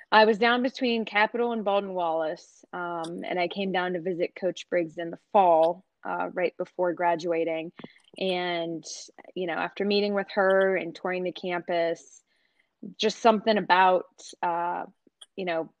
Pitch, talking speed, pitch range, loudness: 180 Hz, 155 wpm, 170-205 Hz, -26 LUFS